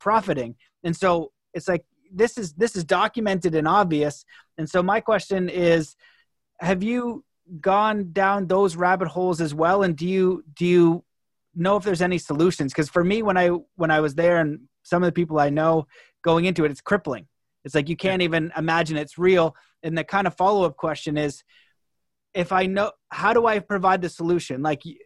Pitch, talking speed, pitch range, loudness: 175 Hz, 195 wpm, 160-195 Hz, -22 LUFS